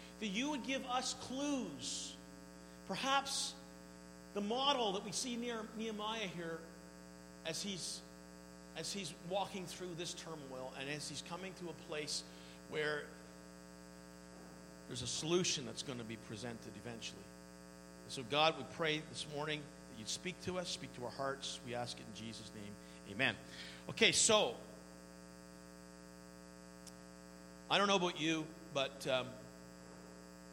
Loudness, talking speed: -39 LUFS, 140 wpm